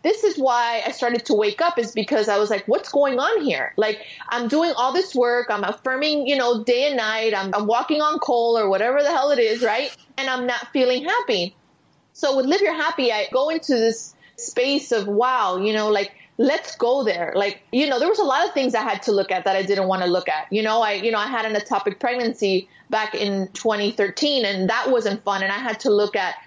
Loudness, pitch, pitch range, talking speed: -21 LUFS, 235 Hz, 210-275 Hz, 245 wpm